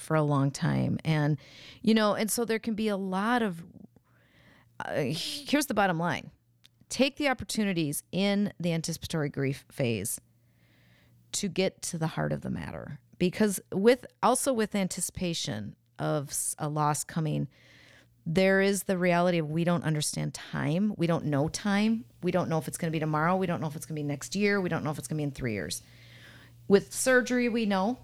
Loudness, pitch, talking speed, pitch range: -29 LUFS, 165 Hz, 195 wpm, 140-200 Hz